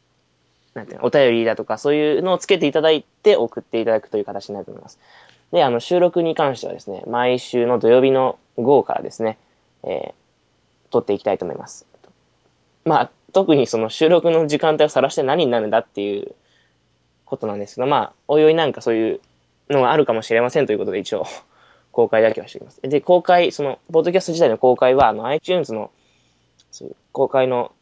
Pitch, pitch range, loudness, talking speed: 120 Hz, 100-150 Hz, -18 LUFS, 415 characters per minute